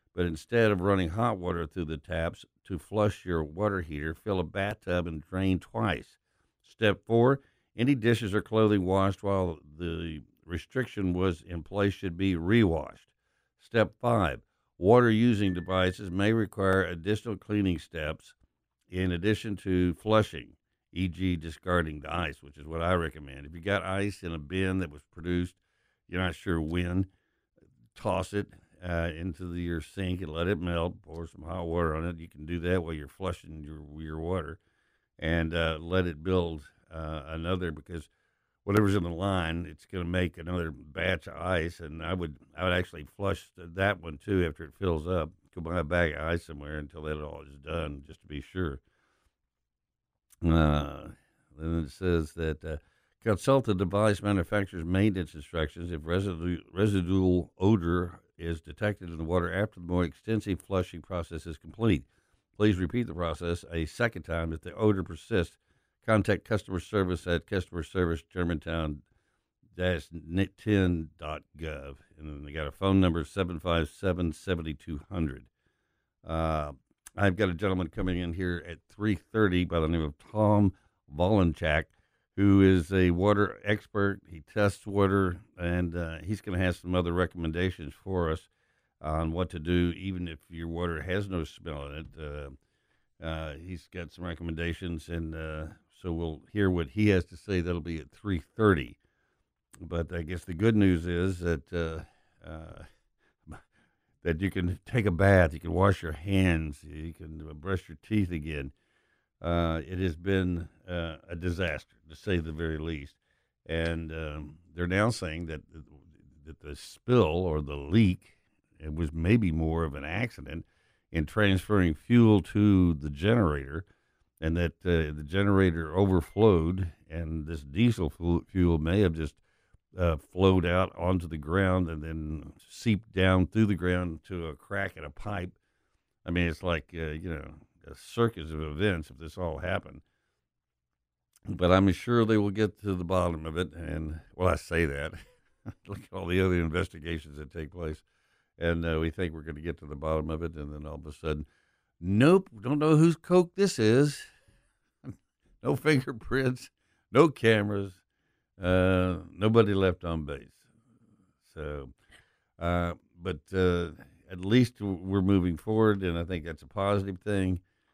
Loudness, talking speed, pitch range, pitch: -29 LUFS, 165 wpm, 80-95 Hz, 90 Hz